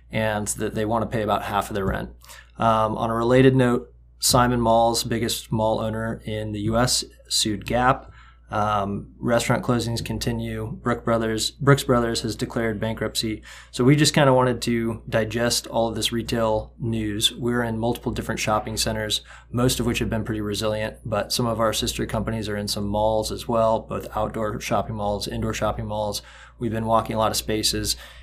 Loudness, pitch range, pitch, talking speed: -23 LUFS, 110-120 Hz, 110 Hz, 185 wpm